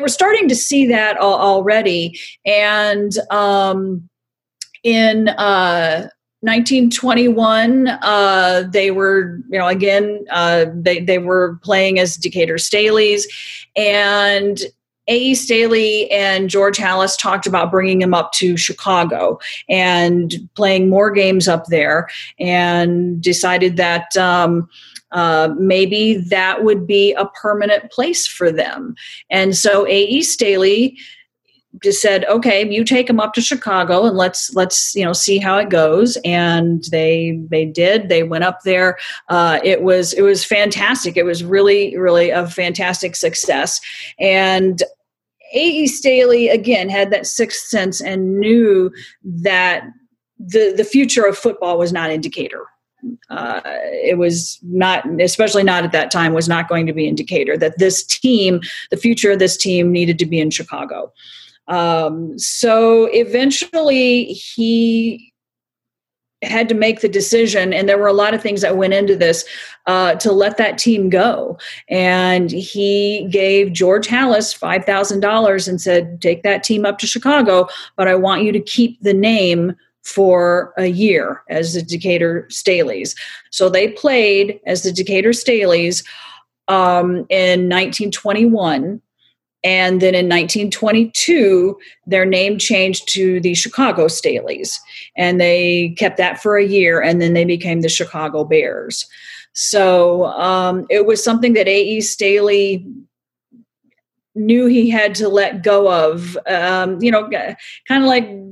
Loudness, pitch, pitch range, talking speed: -14 LUFS, 195 Hz, 180-220 Hz, 145 wpm